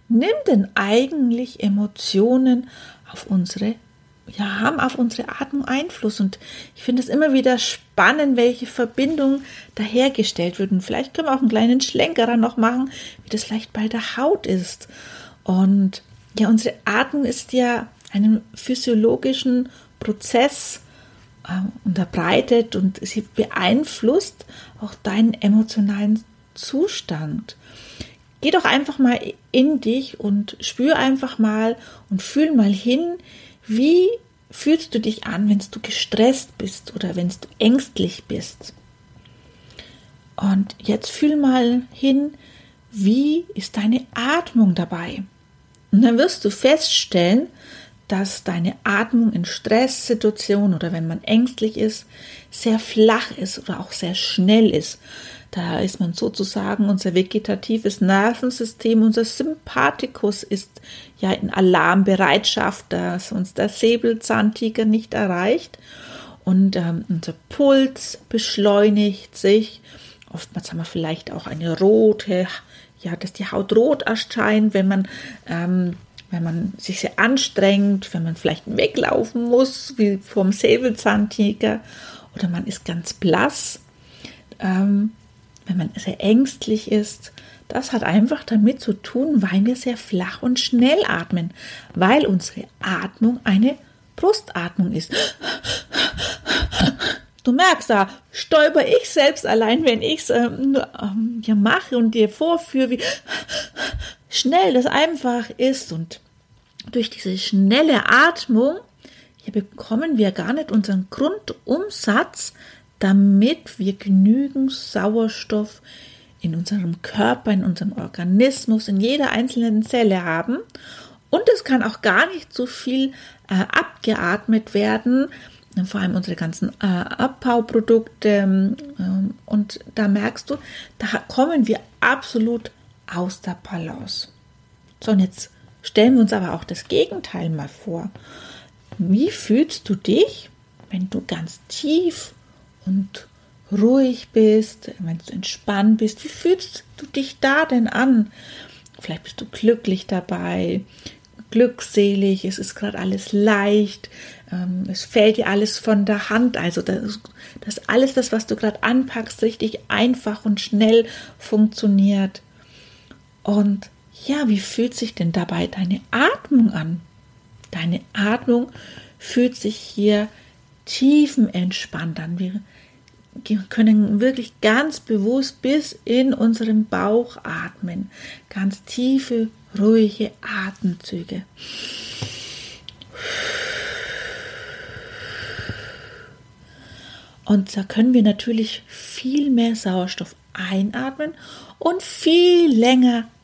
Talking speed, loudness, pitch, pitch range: 120 wpm, -20 LUFS, 220 Hz, 195-250 Hz